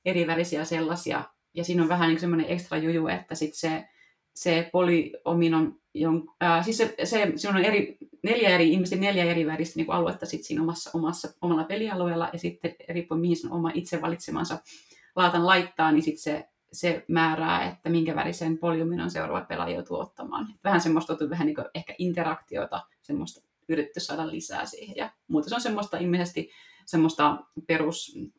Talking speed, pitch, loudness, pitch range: 175 wpm, 165 Hz, -27 LUFS, 160-175 Hz